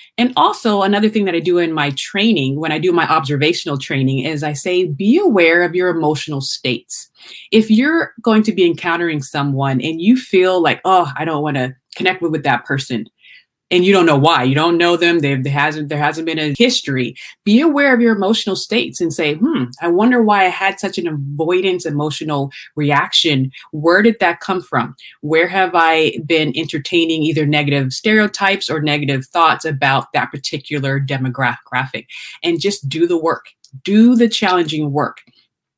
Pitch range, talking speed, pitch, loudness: 145-185 Hz, 185 wpm, 165 Hz, -15 LUFS